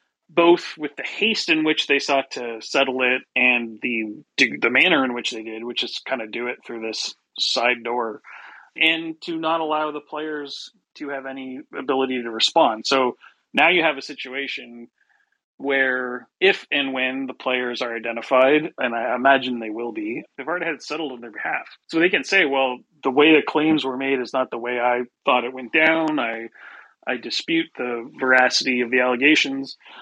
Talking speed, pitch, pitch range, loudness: 195 wpm, 130 Hz, 125-150 Hz, -21 LUFS